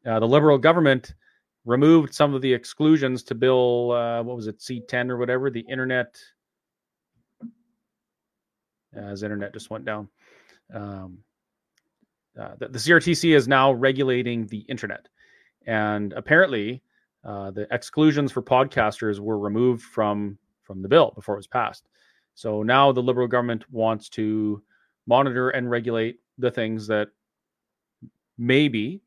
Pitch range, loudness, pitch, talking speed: 110-135 Hz, -22 LUFS, 120 Hz, 140 wpm